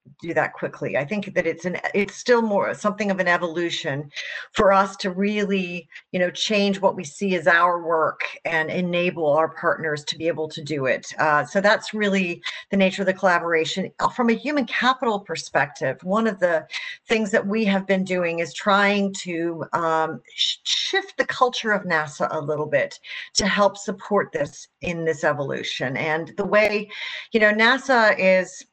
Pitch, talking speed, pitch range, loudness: 190 Hz, 180 wpm, 165-210 Hz, -22 LUFS